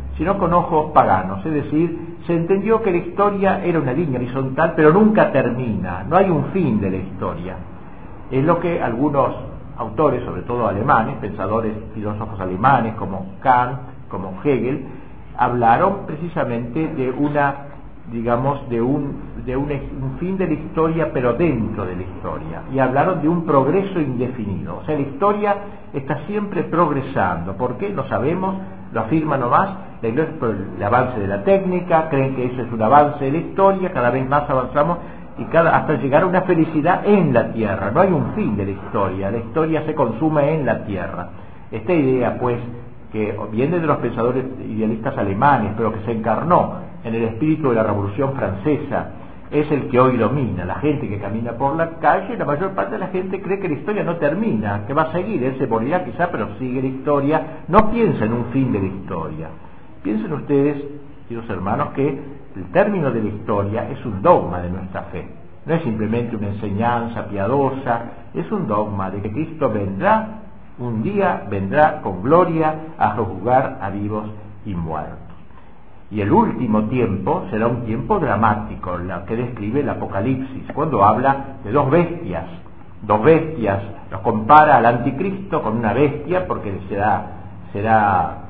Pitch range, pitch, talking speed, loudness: 105-155 Hz, 125 Hz, 175 wpm, -19 LUFS